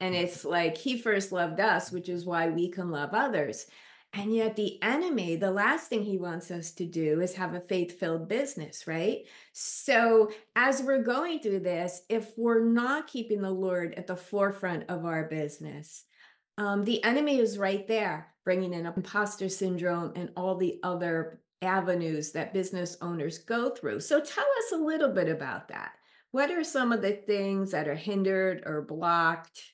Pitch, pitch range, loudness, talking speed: 190 Hz, 175-225 Hz, -30 LUFS, 180 wpm